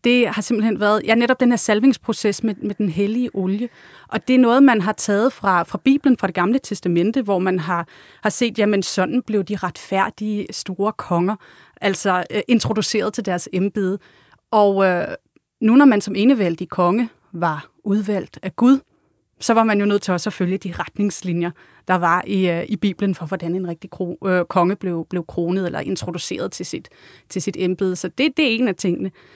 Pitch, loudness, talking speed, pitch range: 200 Hz, -19 LUFS, 200 wpm, 180-220 Hz